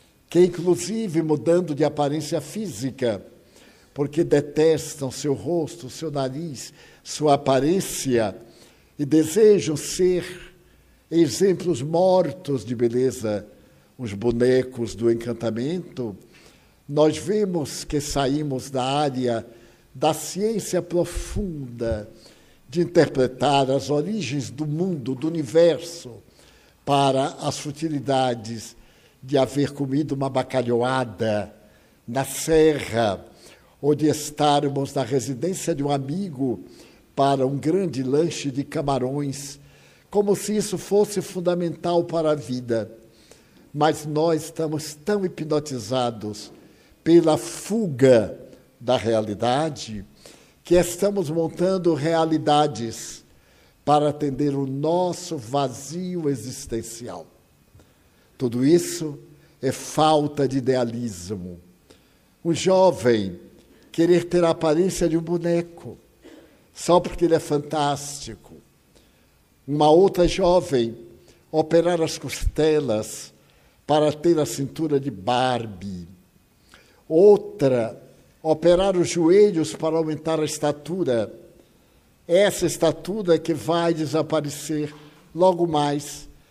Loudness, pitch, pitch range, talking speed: -22 LUFS, 150 Hz, 130-165 Hz, 100 wpm